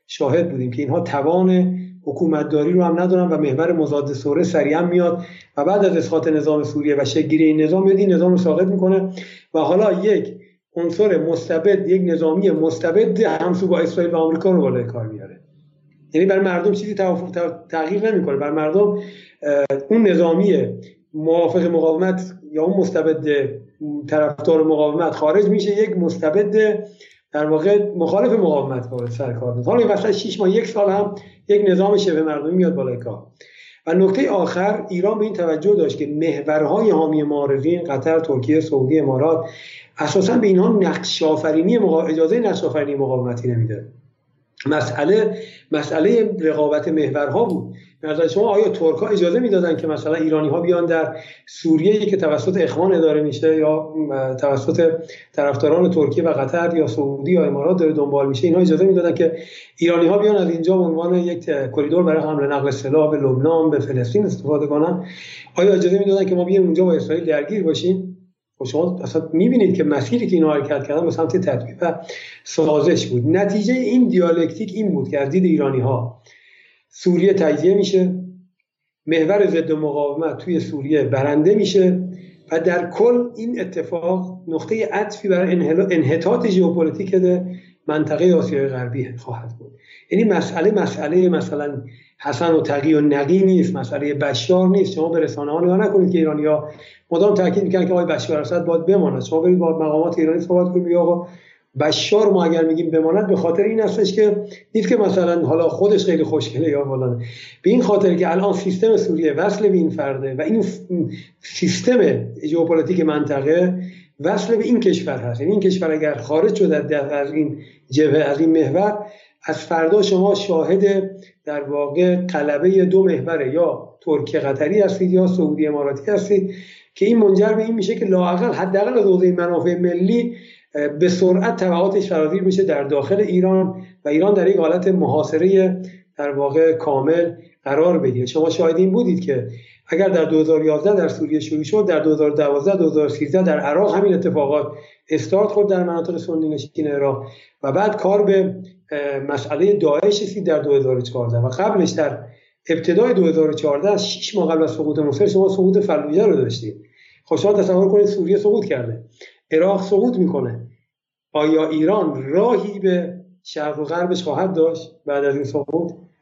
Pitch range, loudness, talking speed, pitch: 150-190 Hz, -18 LUFS, 160 wpm, 165 Hz